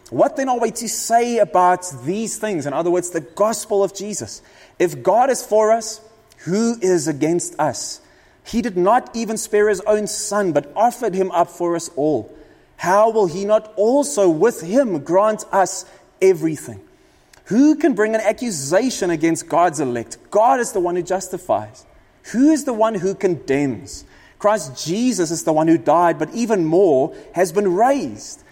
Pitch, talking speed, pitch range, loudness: 205 Hz, 175 wpm, 175-225 Hz, -18 LUFS